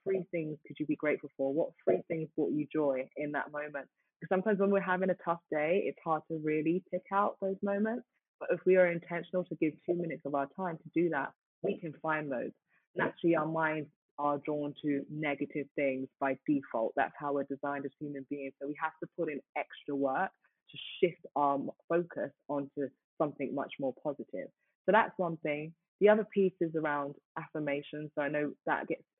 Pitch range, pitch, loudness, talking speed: 145-170 Hz, 155 Hz, -34 LUFS, 210 wpm